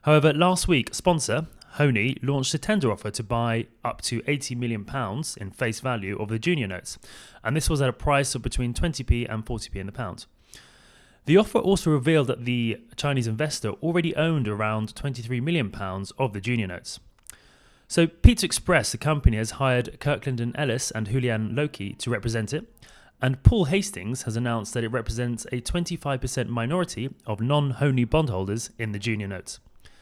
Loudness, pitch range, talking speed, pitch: -25 LUFS, 115-150 Hz, 180 wpm, 125 Hz